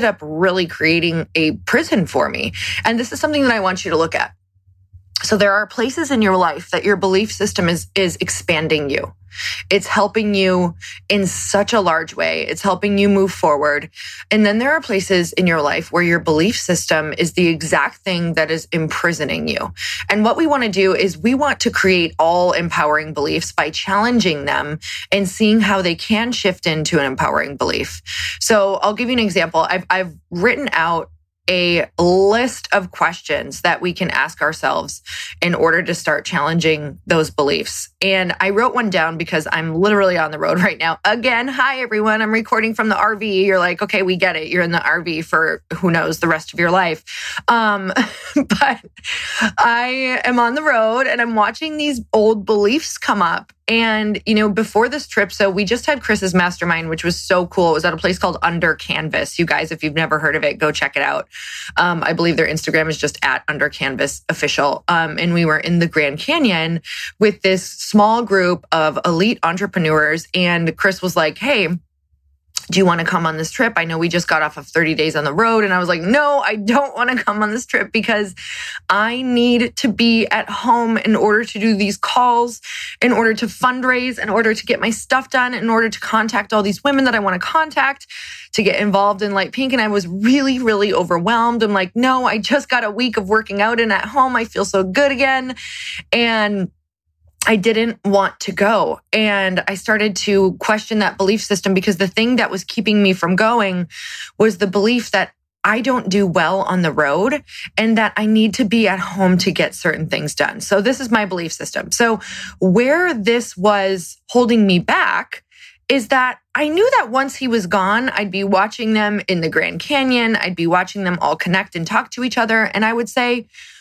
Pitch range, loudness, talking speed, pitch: 170-230 Hz, -16 LUFS, 210 wpm, 200 Hz